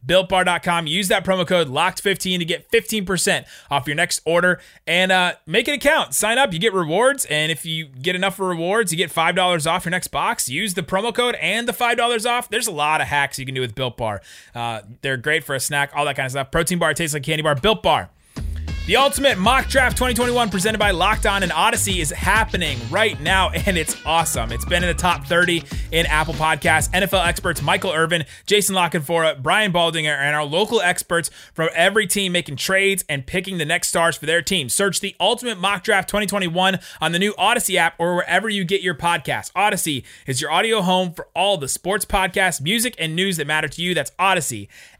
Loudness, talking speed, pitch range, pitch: -19 LUFS, 215 wpm, 155-195 Hz, 180 Hz